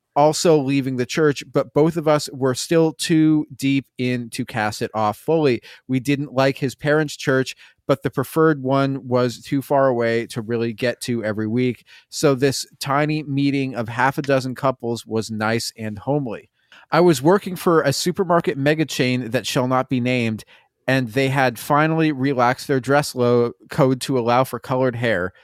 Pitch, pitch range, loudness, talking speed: 135 Hz, 120-145 Hz, -20 LUFS, 180 wpm